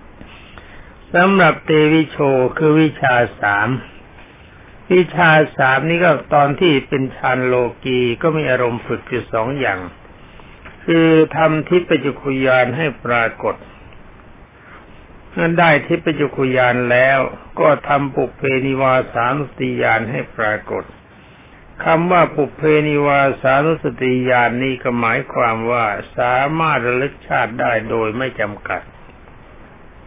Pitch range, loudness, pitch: 125-155 Hz, -16 LUFS, 135 Hz